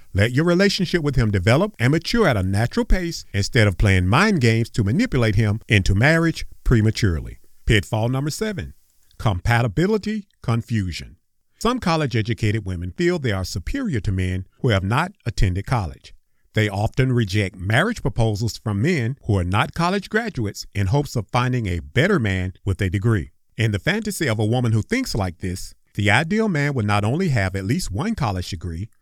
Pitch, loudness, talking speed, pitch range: 115 Hz, -21 LUFS, 180 wpm, 100-145 Hz